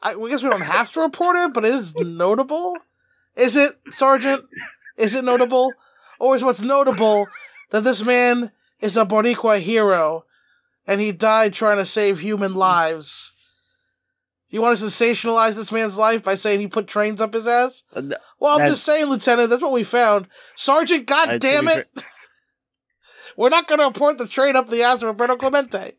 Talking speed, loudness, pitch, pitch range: 175 wpm, -18 LUFS, 240 Hz, 215-275 Hz